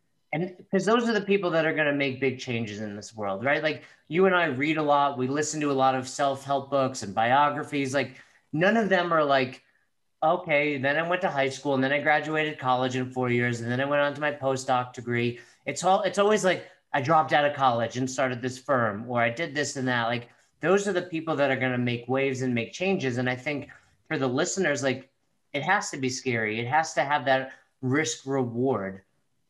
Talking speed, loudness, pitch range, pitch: 235 wpm, -26 LUFS, 130-155 Hz, 140 Hz